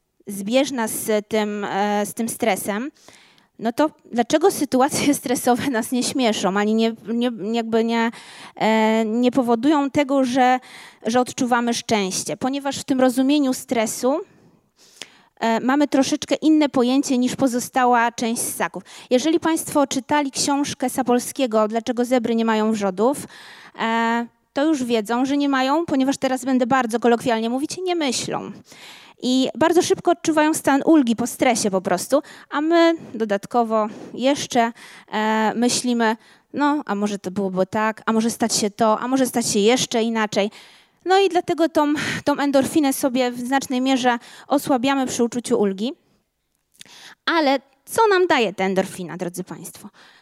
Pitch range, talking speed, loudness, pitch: 225-280 Hz, 140 wpm, -20 LUFS, 250 Hz